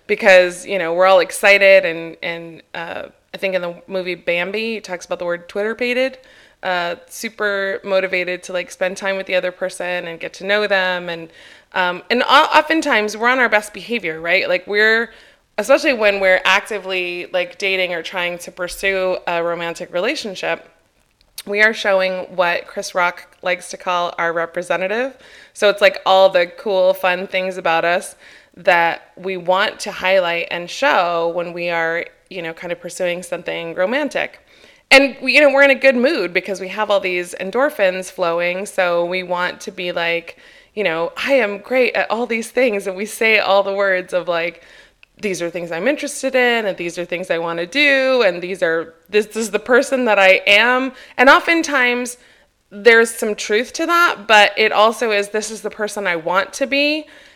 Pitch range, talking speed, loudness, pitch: 180-225 Hz, 190 wpm, -17 LUFS, 190 Hz